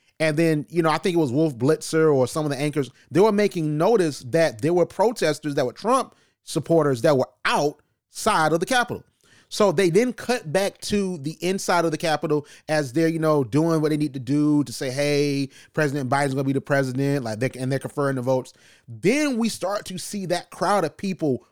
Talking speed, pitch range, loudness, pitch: 225 wpm, 140-170 Hz, -23 LUFS, 155 Hz